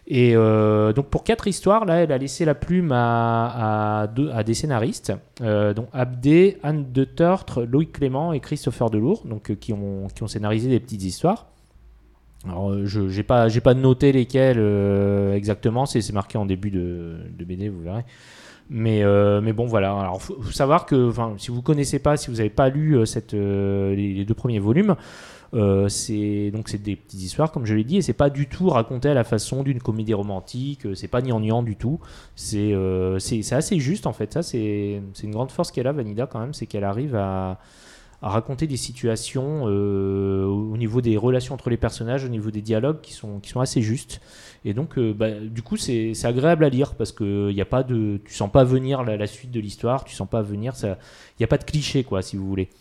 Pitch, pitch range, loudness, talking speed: 115 Hz, 105-135 Hz, -22 LUFS, 230 wpm